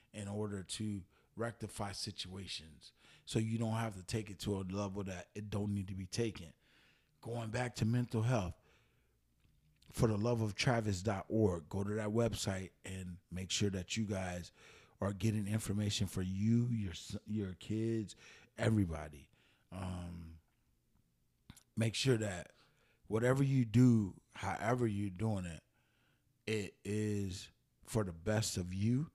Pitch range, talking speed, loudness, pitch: 95-110 Hz, 140 wpm, -38 LUFS, 105 Hz